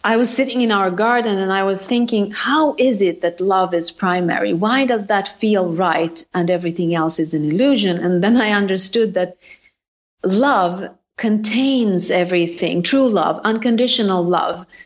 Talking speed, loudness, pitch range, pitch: 160 wpm, -17 LUFS, 180-235 Hz, 195 Hz